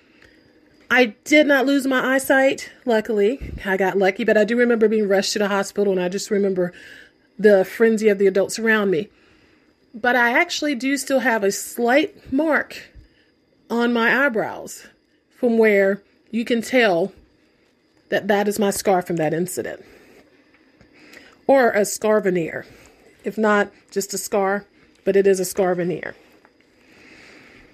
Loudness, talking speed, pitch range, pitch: -19 LUFS, 150 wpm, 195-255 Hz, 215 Hz